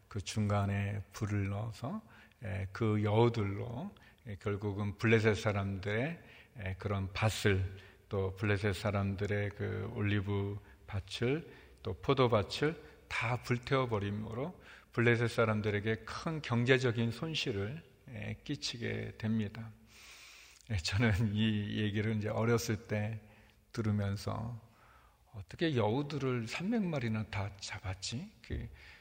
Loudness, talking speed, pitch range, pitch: -35 LUFS, 225 characters per minute, 100-120 Hz, 110 Hz